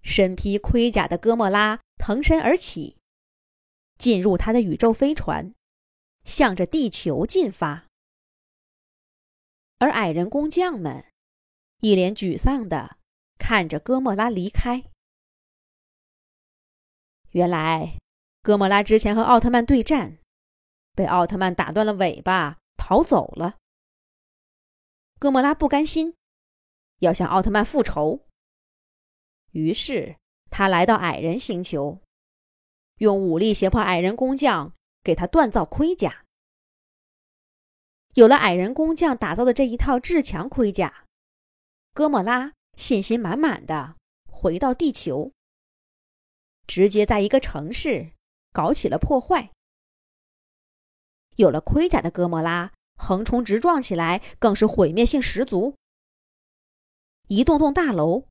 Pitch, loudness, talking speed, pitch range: 220 Hz, -21 LUFS, 175 characters per minute, 185-265 Hz